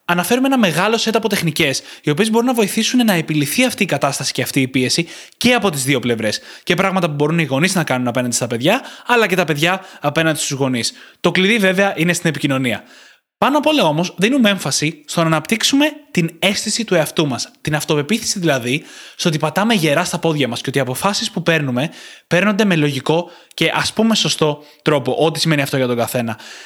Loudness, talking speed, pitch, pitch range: -16 LUFS, 210 wpm, 165 Hz, 145-200 Hz